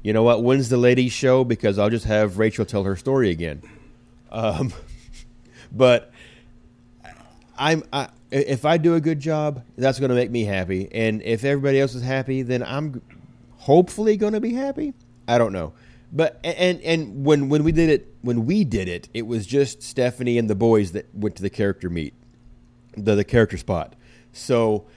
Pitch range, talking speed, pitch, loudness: 110-140 Hz, 190 wpm, 120 Hz, -21 LUFS